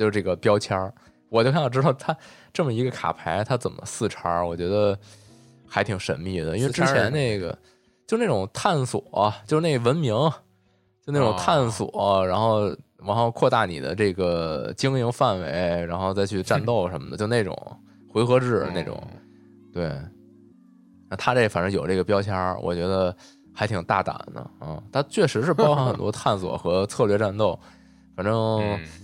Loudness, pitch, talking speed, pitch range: -24 LUFS, 105 Hz, 255 characters per minute, 95-125 Hz